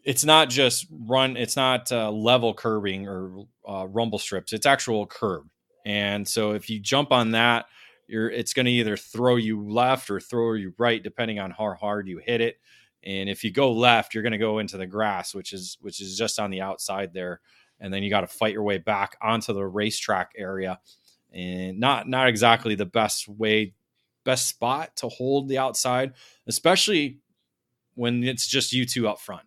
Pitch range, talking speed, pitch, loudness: 100-125 Hz, 200 wpm, 110 Hz, -24 LUFS